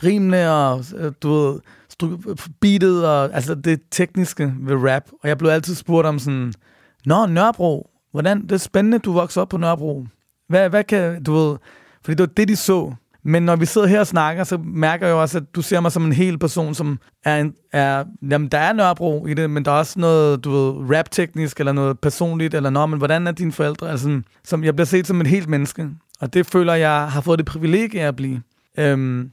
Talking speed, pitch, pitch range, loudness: 220 wpm, 160 Hz, 145-175 Hz, -18 LUFS